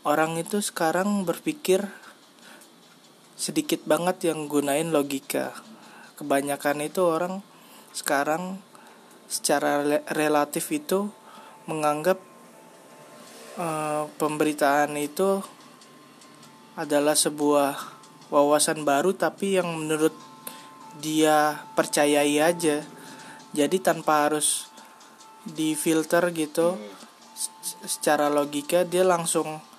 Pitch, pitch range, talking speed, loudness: 155 Hz, 150-180 Hz, 80 wpm, -25 LUFS